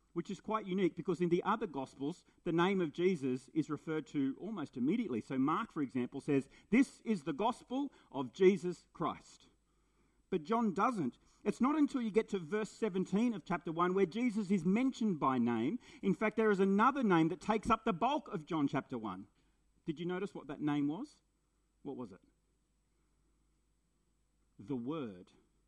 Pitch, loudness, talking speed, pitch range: 185 Hz, -36 LUFS, 180 wpm, 150-220 Hz